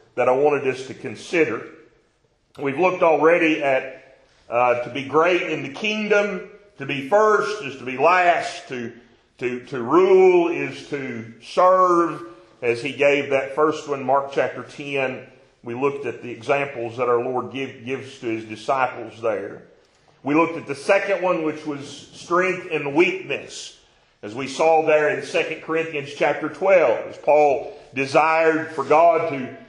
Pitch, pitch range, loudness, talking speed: 150 Hz, 130-180 Hz, -21 LUFS, 160 wpm